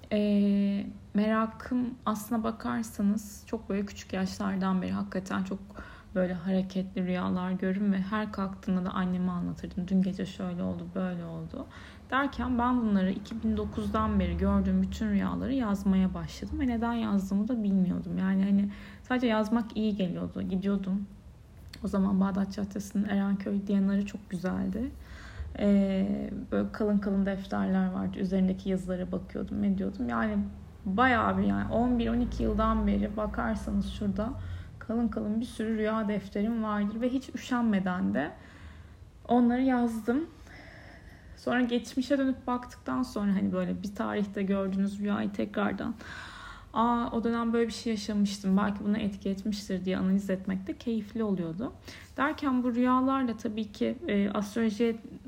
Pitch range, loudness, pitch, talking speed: 190-225 Hz, -30 LUFS, 205 Hz, 135 wpm